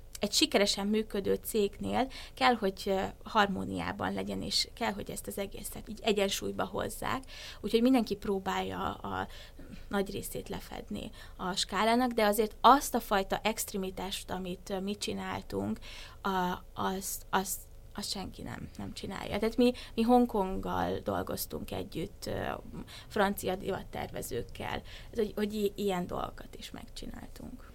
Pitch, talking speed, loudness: 195 Hz, 120 wpm, -32 LUFS